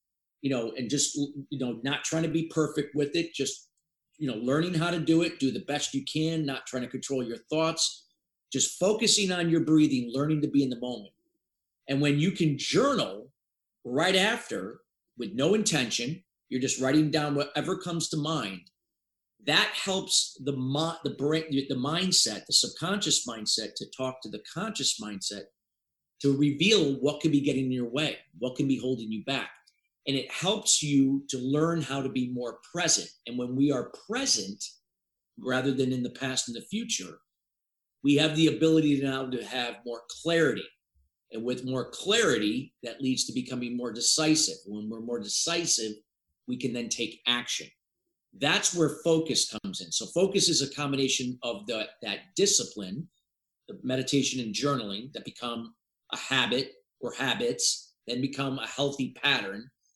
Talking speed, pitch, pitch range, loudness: 175 wpm, 140 Hz, 125-160 Hz, -28 LUFS